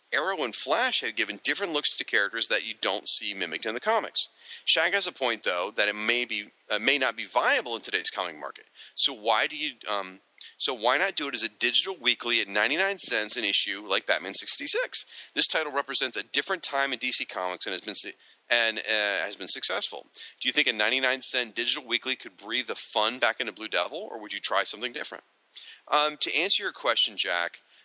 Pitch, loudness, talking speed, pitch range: 125 Hz, -25 LUFS, 220 wpm, 105-150 Hz